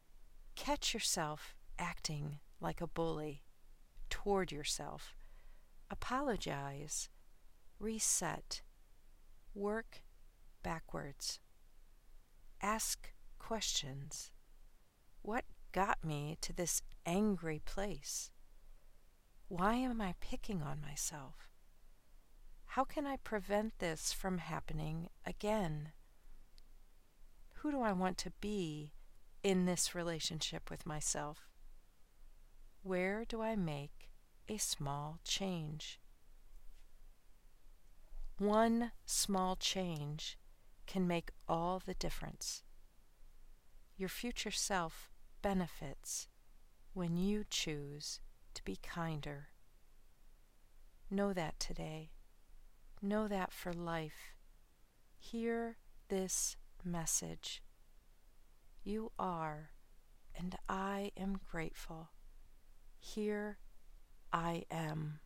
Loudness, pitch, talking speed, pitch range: -41 LUFS, 165 Hz, 85 wpm, 140-200 Hz